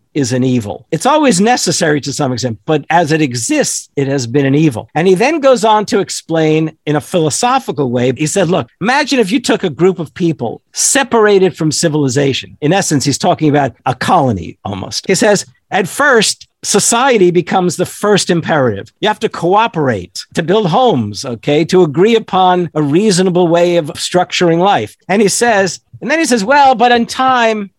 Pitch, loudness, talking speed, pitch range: 175 Hz, -12 LUFS, 190 wpm, 145-210 Hz